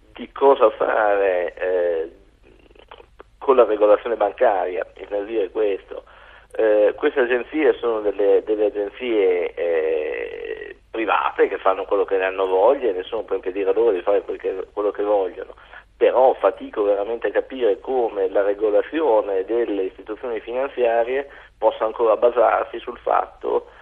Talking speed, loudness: 140 wpm, -20 LUFS